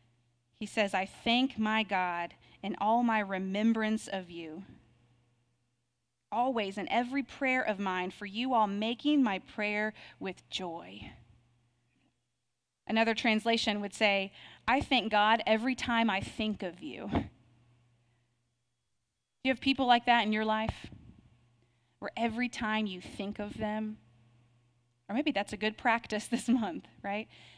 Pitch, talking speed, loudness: 200 Hz, 140 wpm, -31 LUFS